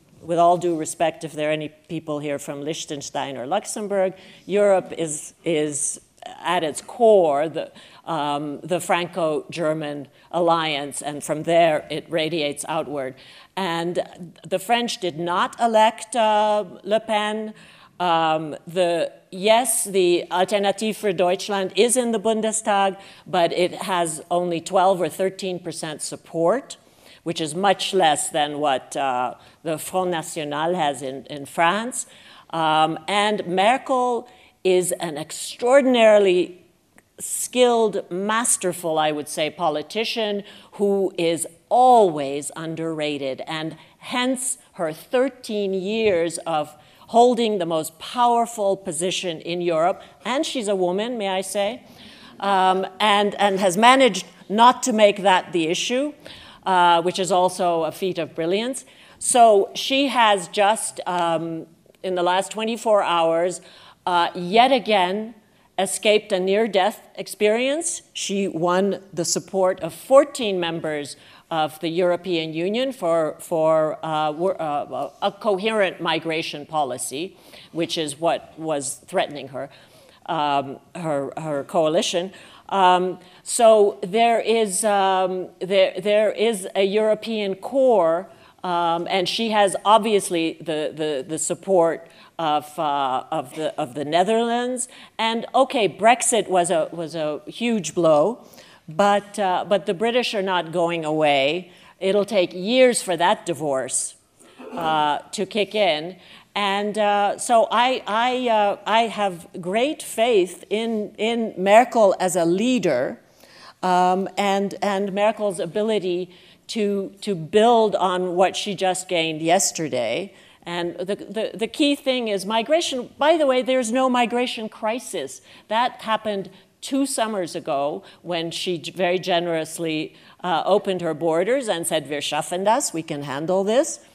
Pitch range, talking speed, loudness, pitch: 165-215 Hz, 135 wpm, -21 LUFS, 185 Hz